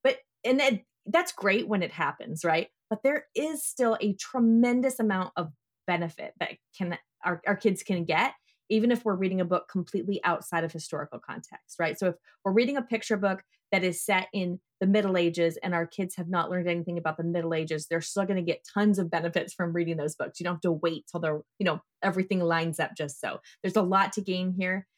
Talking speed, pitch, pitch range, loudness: 225 wpm, 185 Hz, 170-205 Hz, -29 LUFS